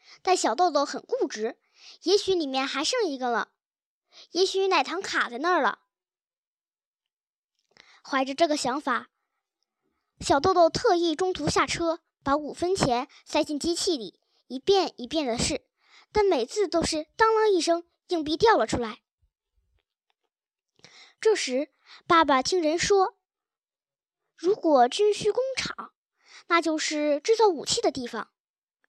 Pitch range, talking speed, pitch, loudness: 295-395 Hz, 195 characters per minute, 340 Hz, -25 LUFS